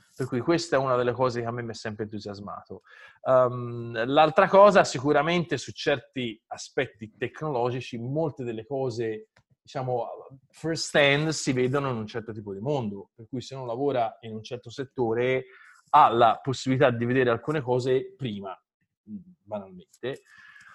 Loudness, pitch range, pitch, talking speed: -25 LUFS, 115-150 Hz, 130 Hz, 155 wpm